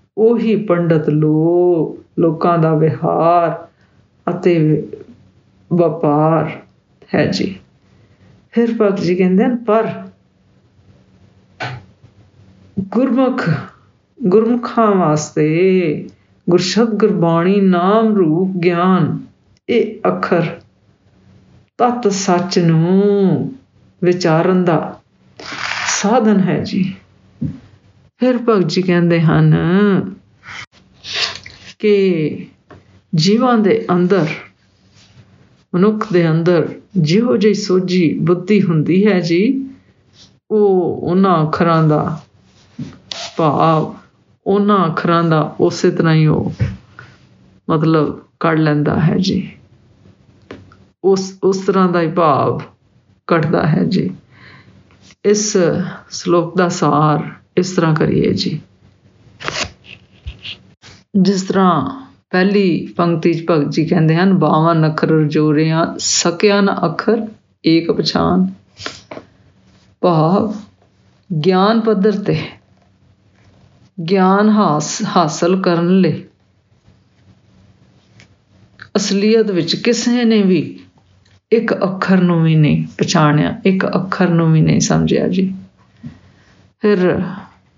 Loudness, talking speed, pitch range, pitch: -15 LUFS, 85 wpm, 150-195 Hz, 175 Hz